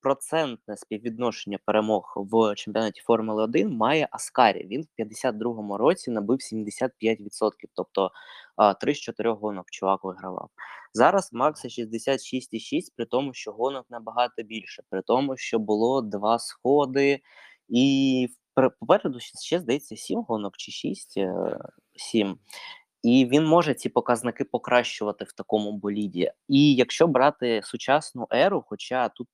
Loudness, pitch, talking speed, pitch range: -25 LUFS, 115 Hz, 125 wpm, 110-130 Hz